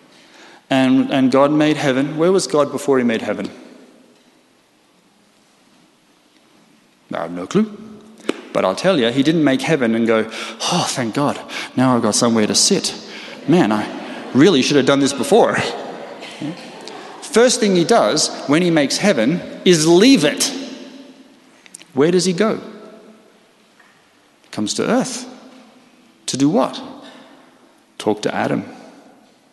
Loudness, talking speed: -16 LUFS, 135 wpm